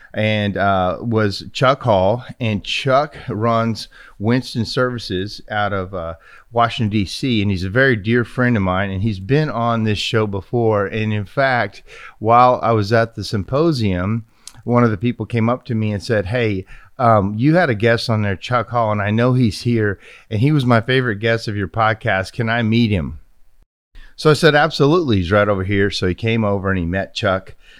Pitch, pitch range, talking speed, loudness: 110 Hz, 100-120 Hz, 200 wpm, -18 LUFS